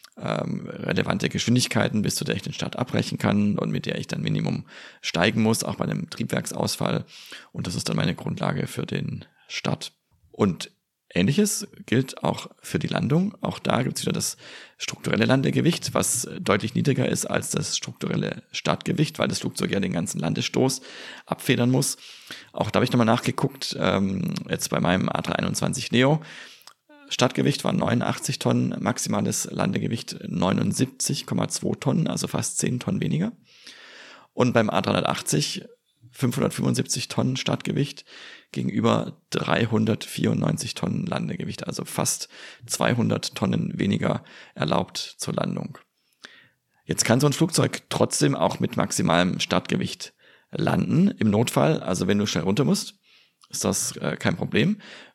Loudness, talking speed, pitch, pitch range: -25 LUFS, 140 wpm, 140 Hz, 110-180 Hz